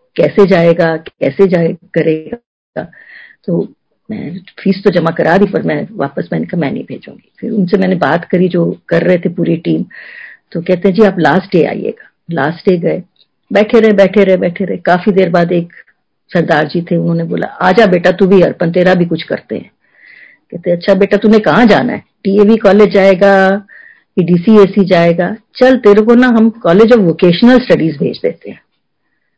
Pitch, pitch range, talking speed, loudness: 190 Hz, 175-210 Hz, 190 wpm, -10 LUFS